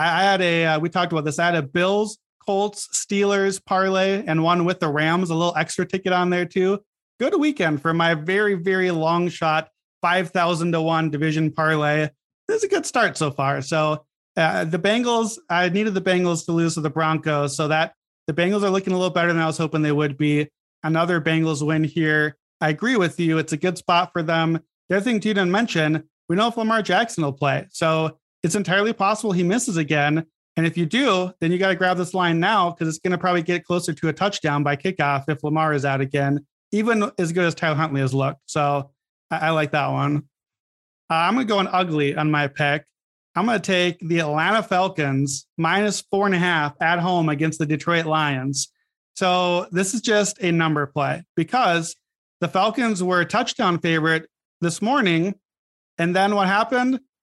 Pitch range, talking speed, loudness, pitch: 155-190 Hz, 215 wpm, -21 LUFS, 170 Hz